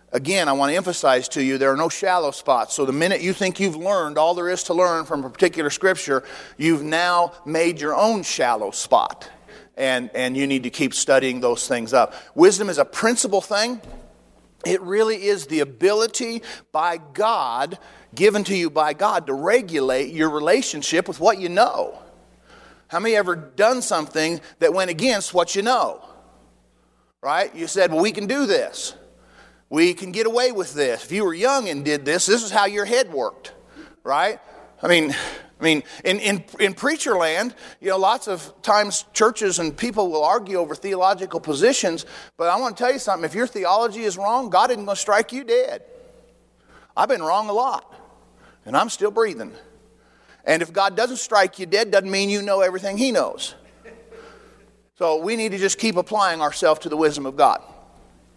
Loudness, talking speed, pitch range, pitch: -21 LUFS, 190 wpm, 155-220 Hz, 190 Hz